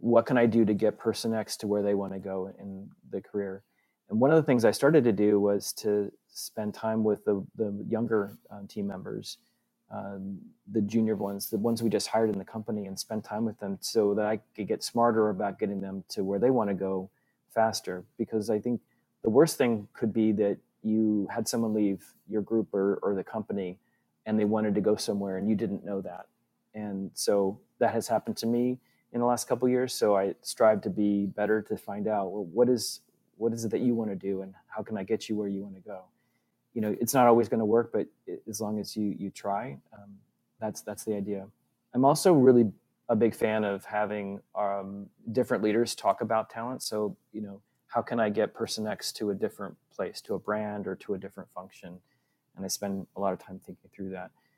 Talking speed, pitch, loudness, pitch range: 230 wpm, 105 Hz, -29 LUFS, 100-115 Hz